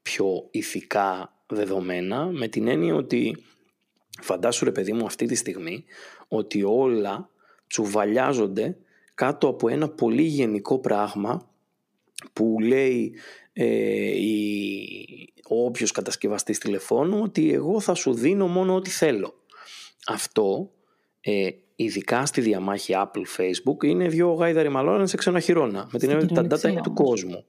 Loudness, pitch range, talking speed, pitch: -24 LUFS, 105-170 Hz, 130 wpm, 125 Hz